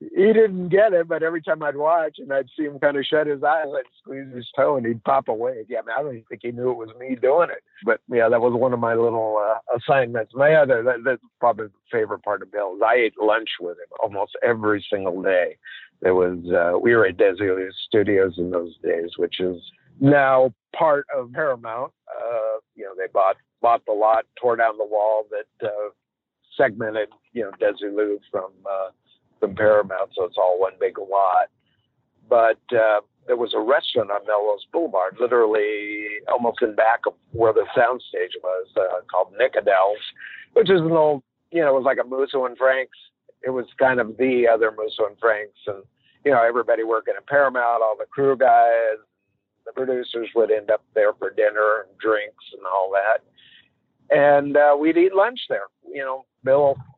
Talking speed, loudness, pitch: 200 wpm, -21 LUFS, 135 Hz